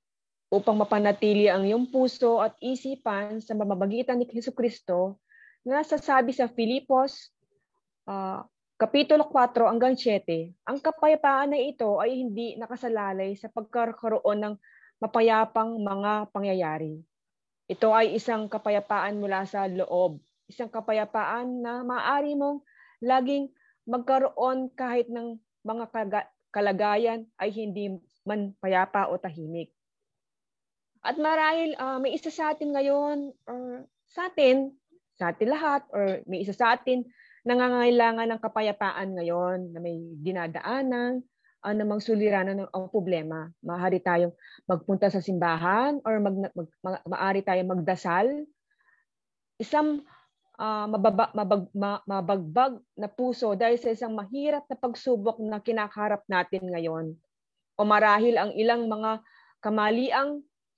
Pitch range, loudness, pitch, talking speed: 195-255 Hz, -27 LUFS, 220 Hz, 120 wpm